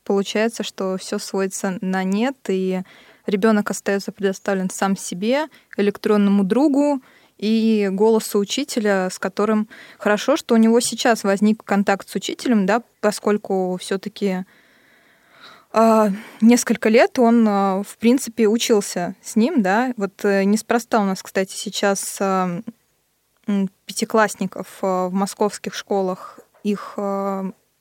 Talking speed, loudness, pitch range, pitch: 110 wpm, -20 LUFS, 195-230 Hz, 210 Hz